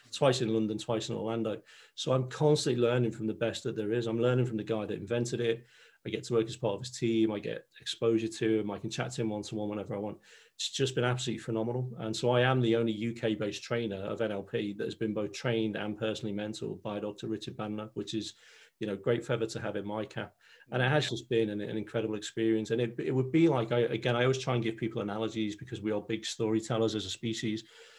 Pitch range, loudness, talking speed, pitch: 110-120 Hz, -32 LUFS, 255 wpm, 115 Hz